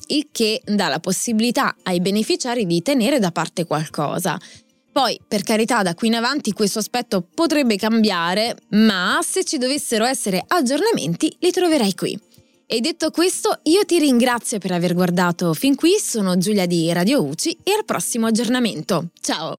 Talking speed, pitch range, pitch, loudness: 160 wpm, 185-285 Hz, 225 Hz, -19 LUFS